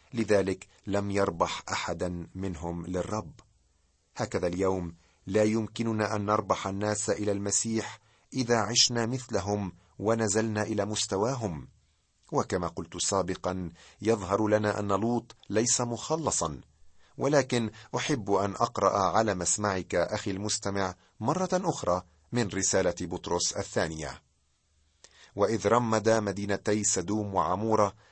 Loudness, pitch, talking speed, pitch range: -29 LUFS, 100 Hz, 105 wpm, 90-110 Hz